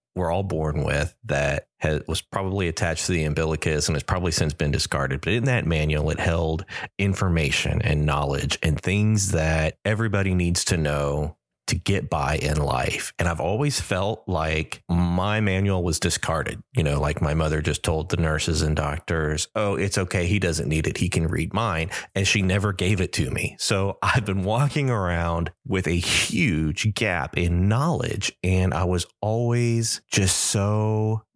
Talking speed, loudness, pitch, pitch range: 180 wpm, -23 LUFS, 90 Hz, 80-100 Hz